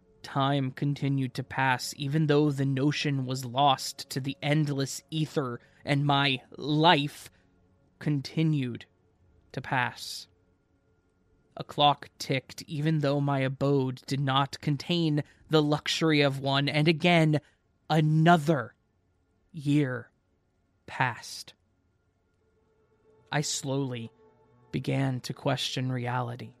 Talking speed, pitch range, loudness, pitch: 100 wpm, 120-150 Hz, -28 LUFS, 135 Hz